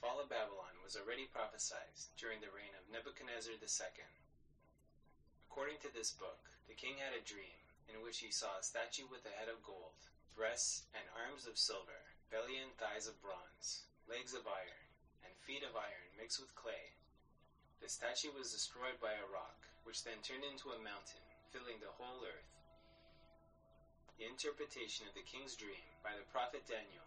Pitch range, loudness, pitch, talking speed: 110-130 Hz, -47 LUFS, 115 Hz, 175 wpm